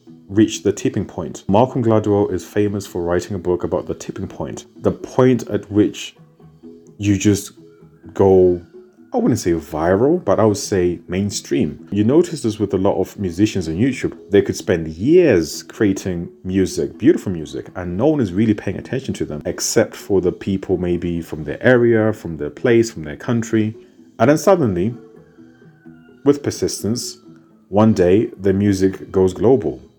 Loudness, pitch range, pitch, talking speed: -18 LUFS, 85-110 Hz, 100 Hz, 170 wpm